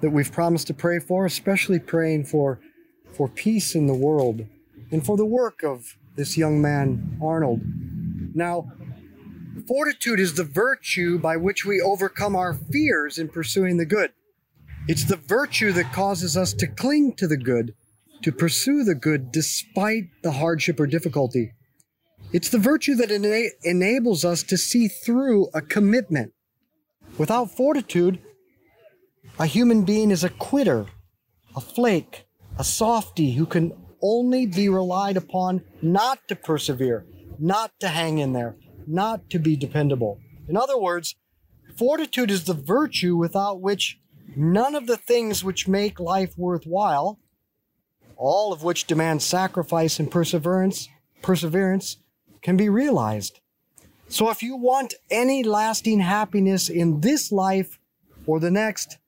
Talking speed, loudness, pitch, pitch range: 145 wpm, -22 LUFS, 180 Hz, 155-215 Hz